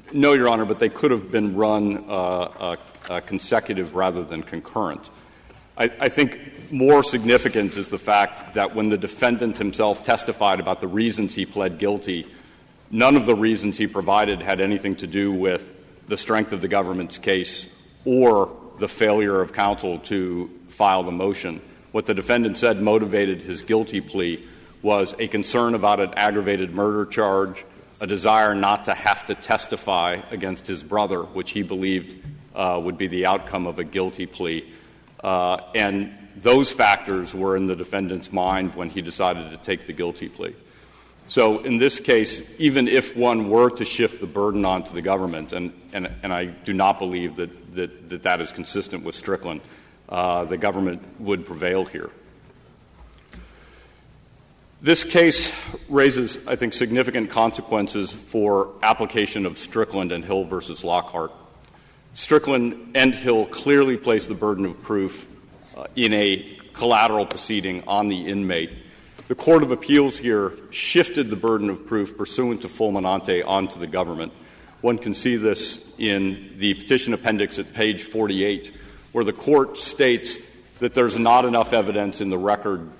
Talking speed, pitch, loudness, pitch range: 160 wpm, 100 Hz, -21 LUFS, 95-115 Hz